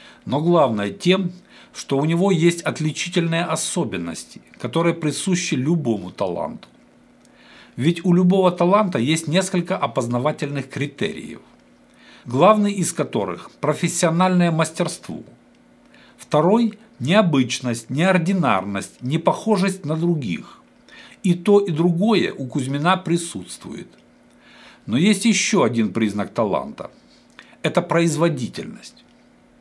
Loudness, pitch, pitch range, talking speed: -20 LUFS, 170 Hz, 145-185 Hz, 95 wpm